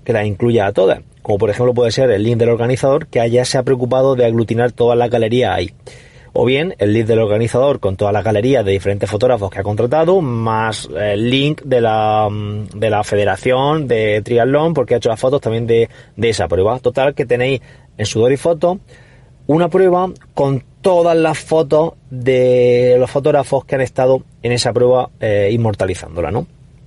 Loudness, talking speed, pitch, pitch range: -15 LUFS, 190 wpm, 125 Hz, 110-135 Hz